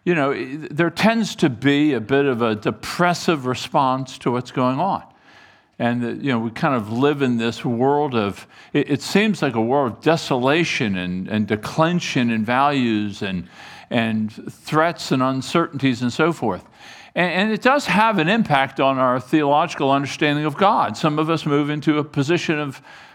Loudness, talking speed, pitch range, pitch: -20 LUFS, 175 wpm, 120-160 Hz, 140 Hz